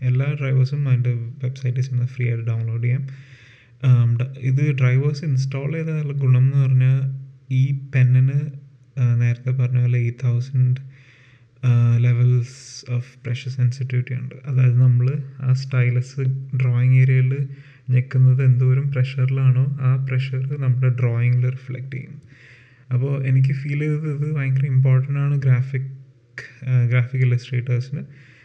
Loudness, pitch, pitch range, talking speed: -20 LUFS, 130 Hz, 125-135 Hz, 115 wpm